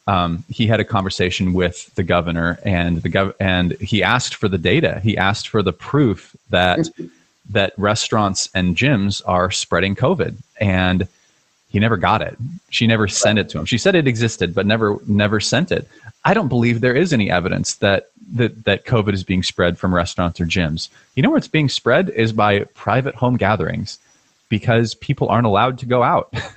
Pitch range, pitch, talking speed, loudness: 95-115 Hz, 105 Hz, 195 wpm, -18 LUFS